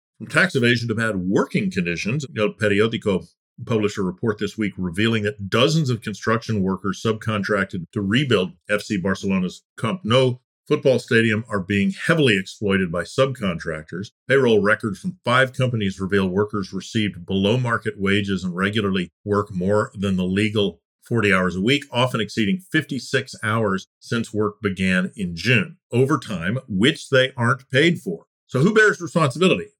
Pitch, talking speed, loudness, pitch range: 110 Hz, 150 wpm, -21 LUFS, 100-130 Hz